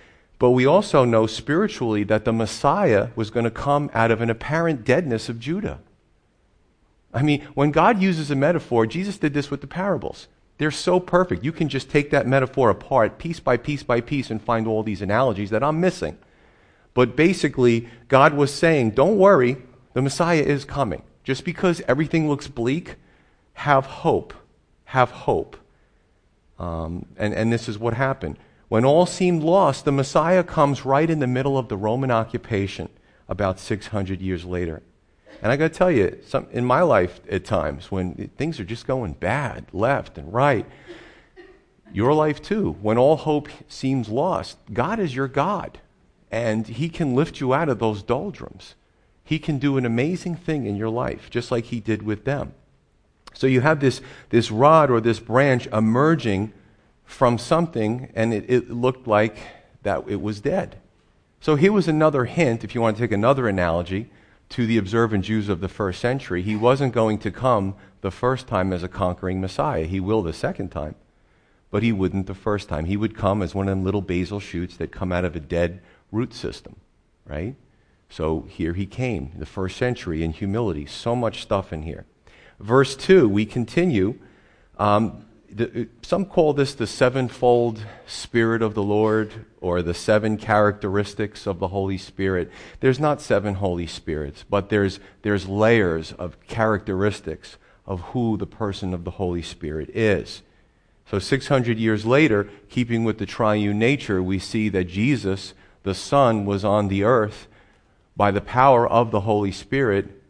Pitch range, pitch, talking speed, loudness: 100-135 Hz, 115 Hz, 175 wpm, -22 LUFS